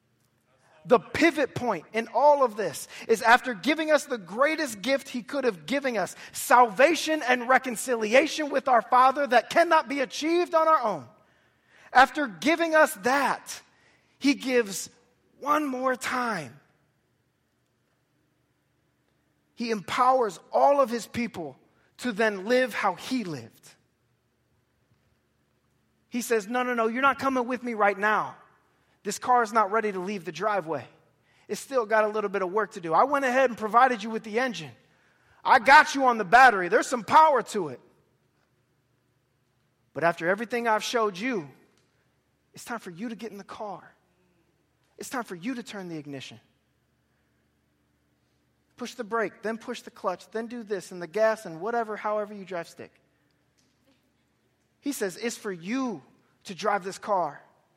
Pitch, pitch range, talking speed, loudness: 225 Hz, 185-255 Hz, 160 wpm, -25 LUFS